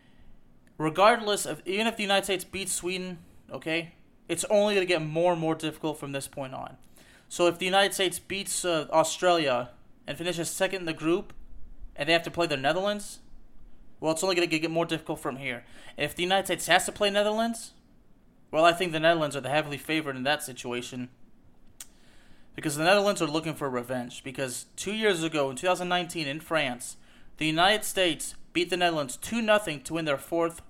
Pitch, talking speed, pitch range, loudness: 165 Hz, 200 wpm, 150-185 Hz, -27 LUFS